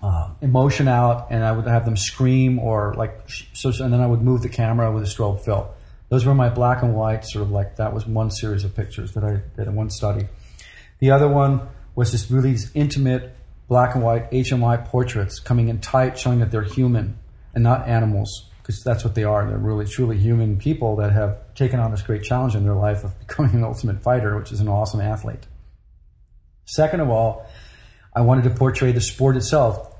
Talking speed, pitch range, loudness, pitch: 215 wpm, 105-125 Hz, -20 LUFS, 115 Hz